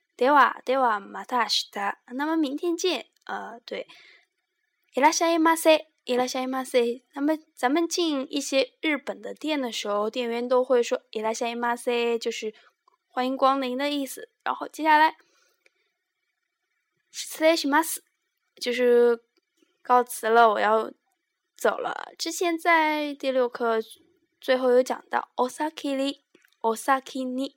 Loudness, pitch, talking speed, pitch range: -25 LUFS, 275 Hz, 215 characters per minute, 245-330 Hz